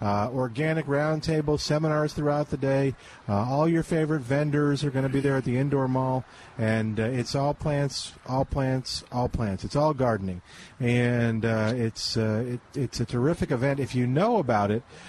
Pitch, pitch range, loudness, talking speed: 130 Hz, 115-145 Hz, -26 LUFS, 185 wpm